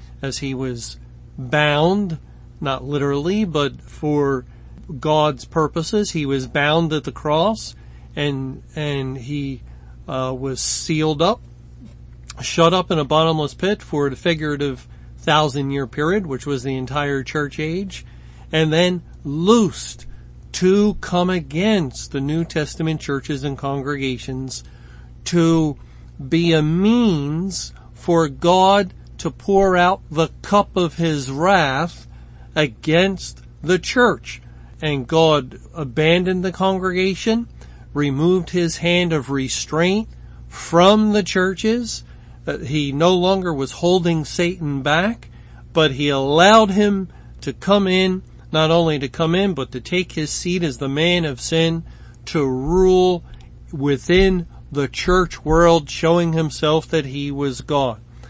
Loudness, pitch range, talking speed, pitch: -19 LUFS, 135-175 Hz, 130 wpm, 155 Hz